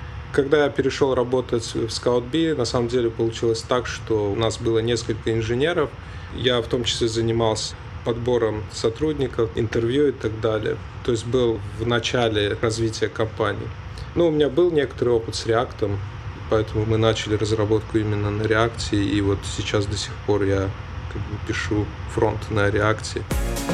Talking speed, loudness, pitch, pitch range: 165 wpm, -23 LUFS, 110 Hz, 105-115 Hz